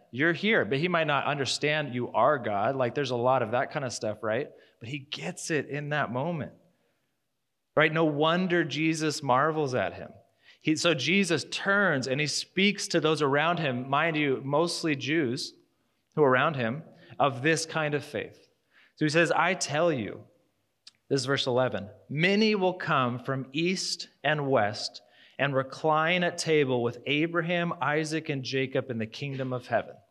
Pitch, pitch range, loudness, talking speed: 150 Hz, 135-165 Hz, -27 LUFS, 175 wpm